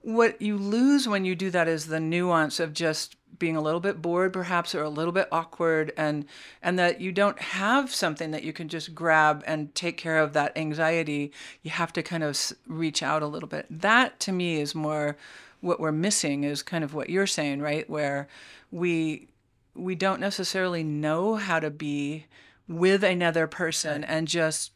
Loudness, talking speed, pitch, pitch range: -26 LUFS, 195 wpm, 165 Hz, 155-180 Hz